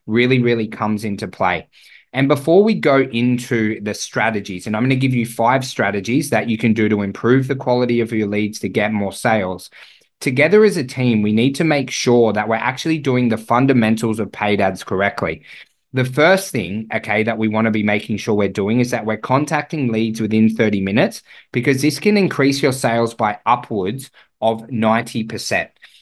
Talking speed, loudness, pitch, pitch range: 195 wpm, -17 LUFS, 115 Hz, 110-130 Hz